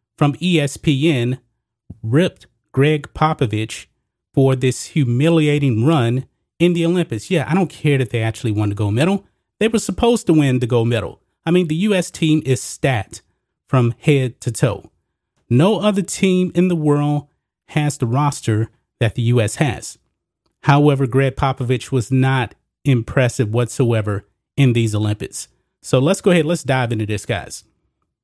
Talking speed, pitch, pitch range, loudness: 155 wpm, 135 Hz, 120-155 Hz, -18 LUFS